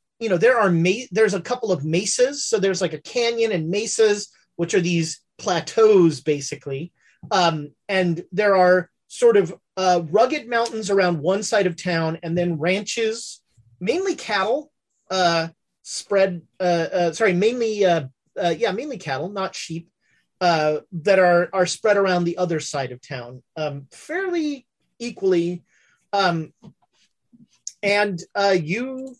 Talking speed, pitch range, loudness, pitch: 150 wpm, 170-220 Hz, -21 LUFS, 185 Hz